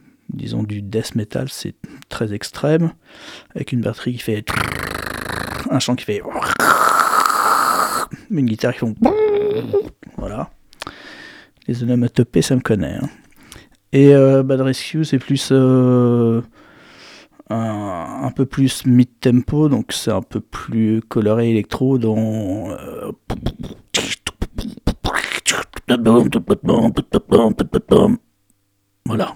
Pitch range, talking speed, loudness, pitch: 110-140 Hz, 100 wpm, -17 LUFS, 125 Hz